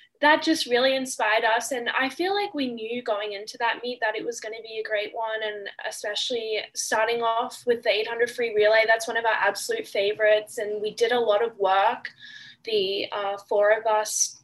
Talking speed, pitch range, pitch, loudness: 210 wpm, 215-245 Hz, 225 Hz, -24 LUFS